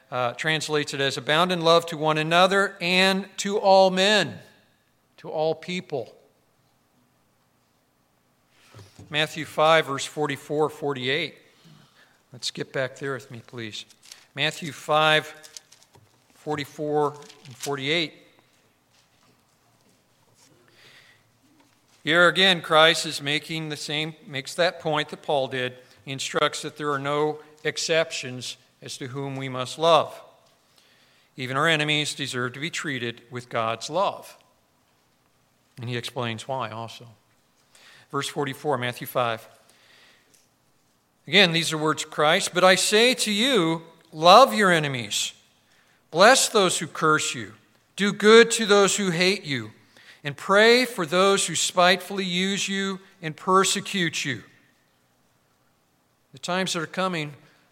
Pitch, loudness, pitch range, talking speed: 150 Hz, -22 LUFS, 130-175 Hz, 125 wpm